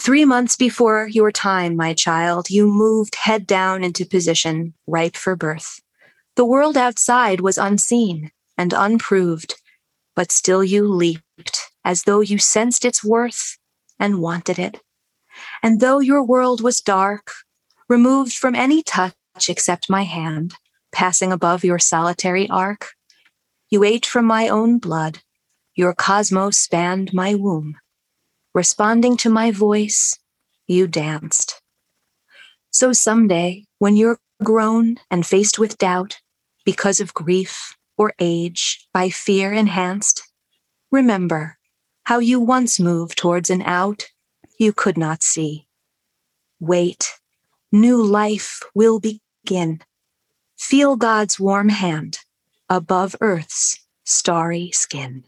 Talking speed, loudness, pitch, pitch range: 125 wpm, -17 LUFS, 195 Hz, 175-225 Hz